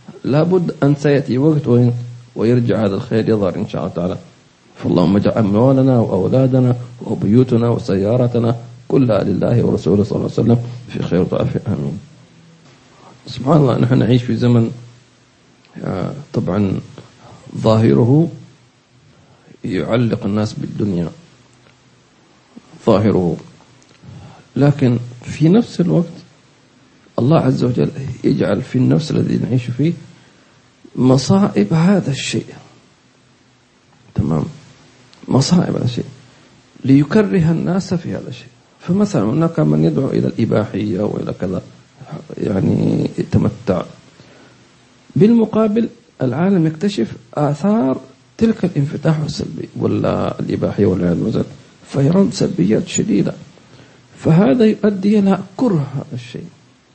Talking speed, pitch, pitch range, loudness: 100 wpm, 130 Hz, 120-165 Hz, -16 LUFS